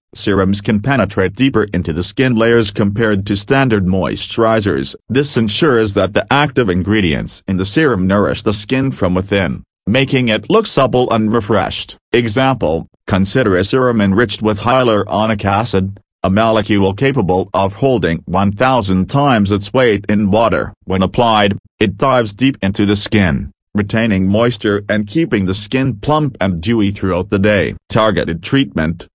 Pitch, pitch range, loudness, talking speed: 105 Hz, 95-120 Hz, -14 LUFS, 150 wpm